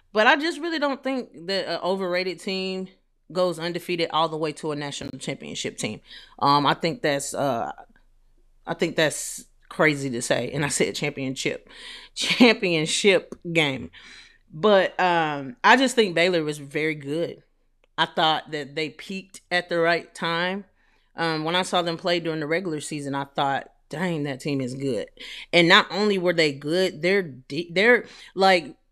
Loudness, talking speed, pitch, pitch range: -23 LUFS, 170 wpm, 170 Hz, 150-185 Hz